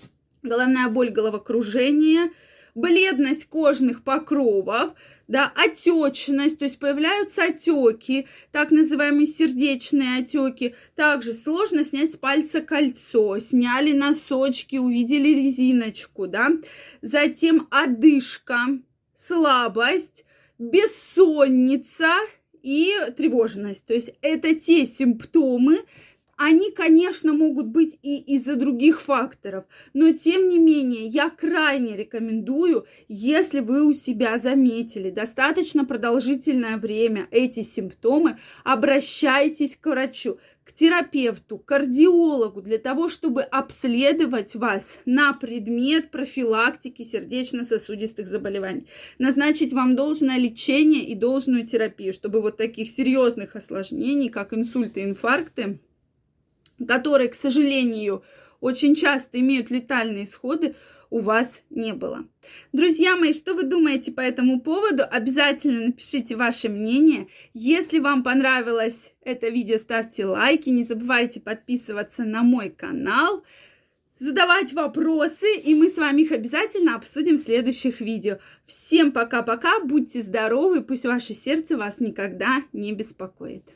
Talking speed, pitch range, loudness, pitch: 110 wpm, 235-305 Hz, -21 LUFS, 270 Hz